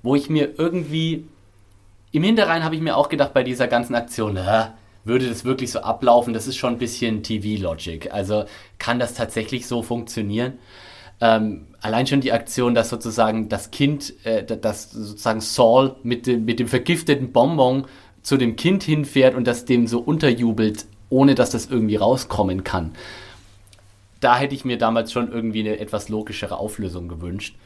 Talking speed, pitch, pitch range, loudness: 170 wpm, 115 Hz, 105-130 Hz, -21 LUFS